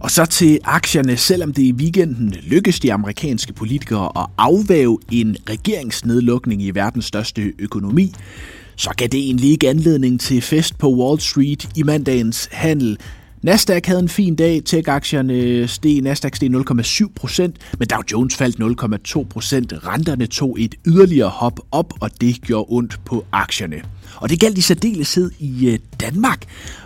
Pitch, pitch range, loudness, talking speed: 125 Hz, 110-155 Hz, -17 LUFS, 150 wpm